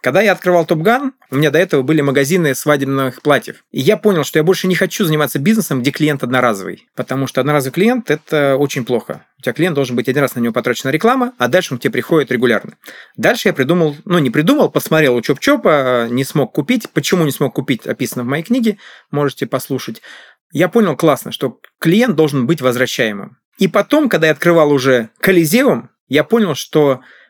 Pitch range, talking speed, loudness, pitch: 130-185 Hz, 200 wpm, -15 LUFS, 150 Hz